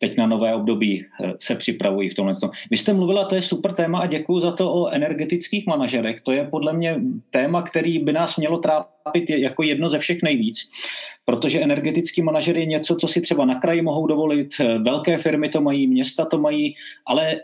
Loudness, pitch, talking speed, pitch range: -21 LUFS, 160 Hz, 195 wpm, 145-175 Hz